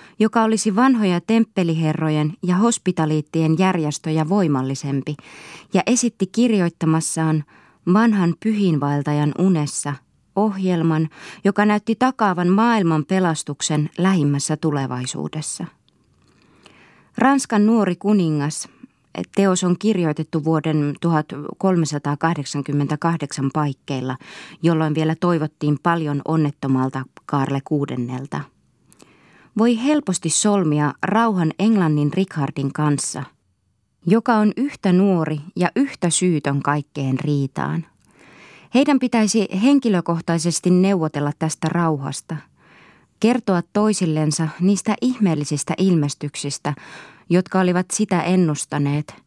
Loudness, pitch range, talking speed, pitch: -20 LUFS, 150-195 Hz, 85 wpm, 165 Hz